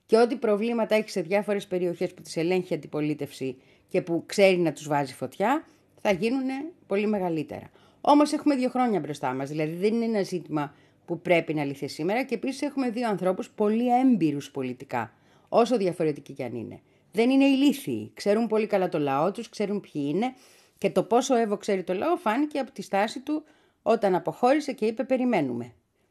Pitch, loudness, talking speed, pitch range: 200 Hz, -26 LUFS, 185 wpm, 160-245 Hz